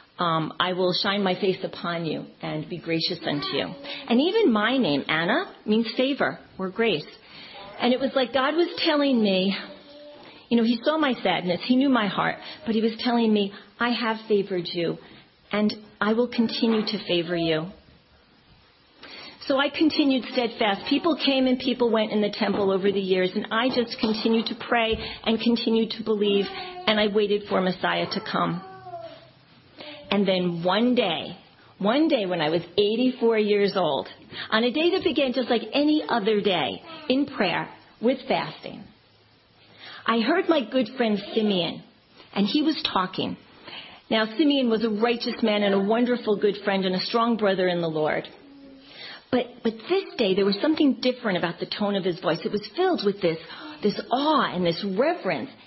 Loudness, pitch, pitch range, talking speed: -24 LUFS, 225 Hz, 200-260 Hz, 180 wpm